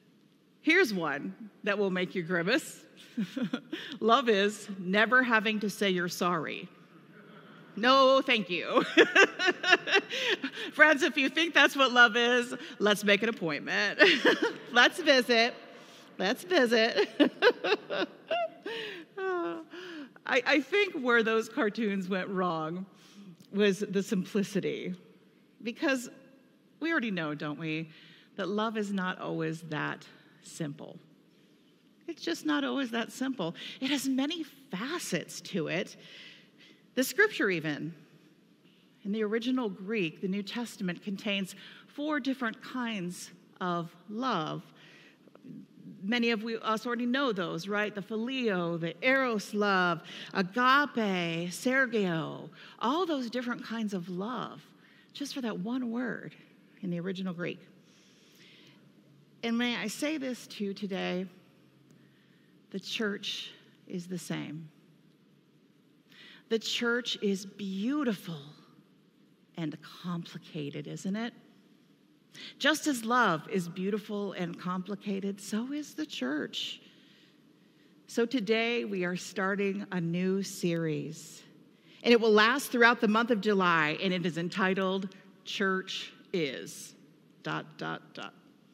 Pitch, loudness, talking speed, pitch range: 215 Hz, -29 LUFS, 120 wpm, 185-255 Hz